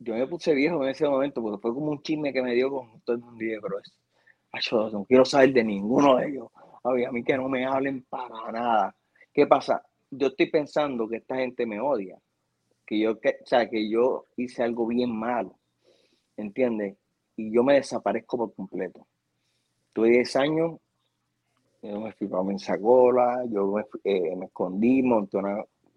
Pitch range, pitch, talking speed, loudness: 110-135 Hz, 120 Hz, 185 wpm, -26 LUFS